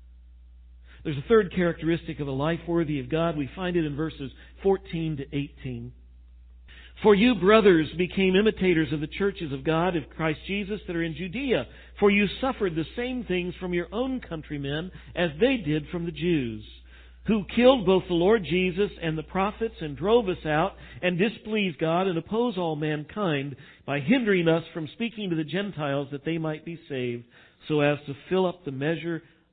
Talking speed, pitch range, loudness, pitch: 185 wpm, 150-195 Hz, -26 LUFS, 165 Hz